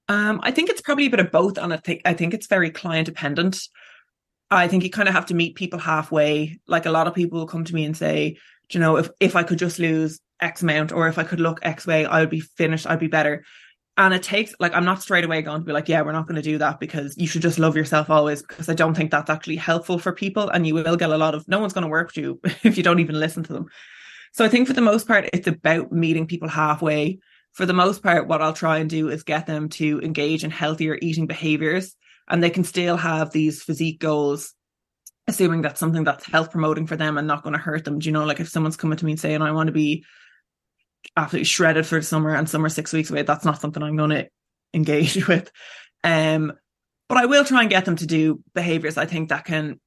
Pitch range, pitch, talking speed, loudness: 155-175 Hz, 160 Hz, 265 wpm, -21 LUFS